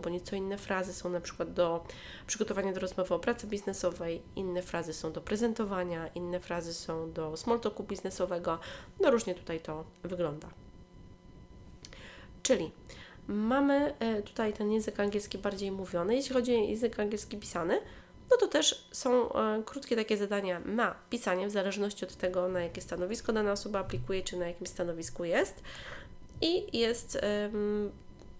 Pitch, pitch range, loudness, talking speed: 195 Hz, 175-215 Hz, -33 LUFS, 150 wpm